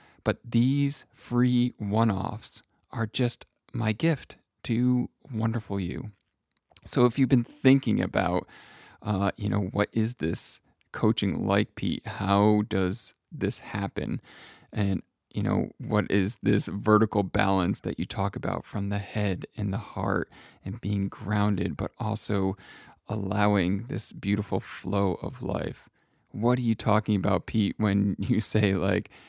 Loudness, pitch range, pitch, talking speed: -27 LUFS, 100-115 Hz, 105 Hz, 145 wpm